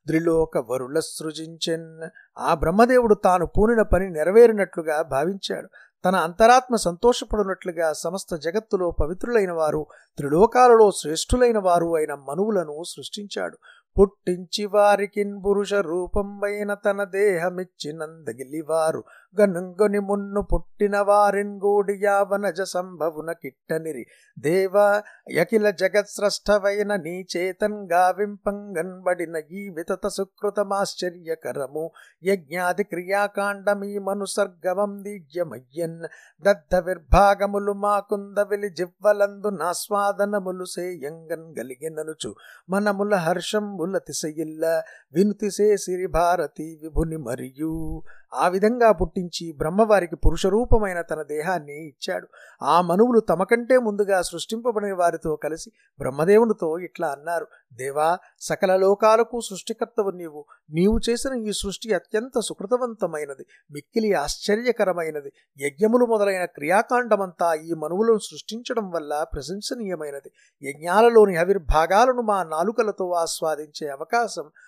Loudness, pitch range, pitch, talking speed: -23 LUFS, 165-205 Hz, 190 Hz, 90 wpm